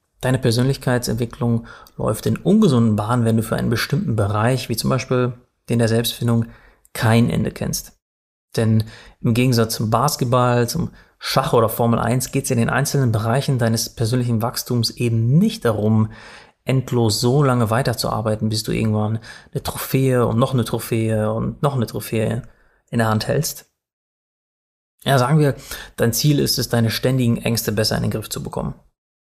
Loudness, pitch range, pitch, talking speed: -19 LUFS, 115-125 Hz, 120 Hz, 165 wpm